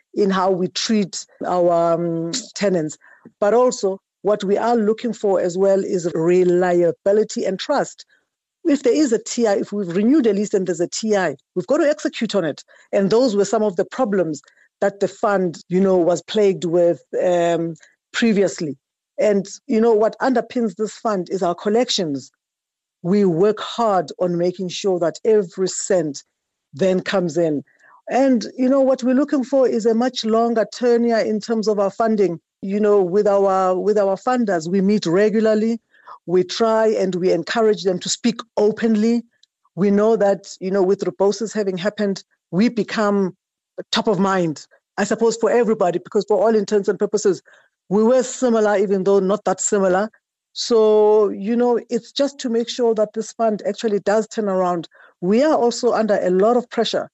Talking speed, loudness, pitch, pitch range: 180 wpm, -19 LUFS, 205 Hz, 185-230 Hz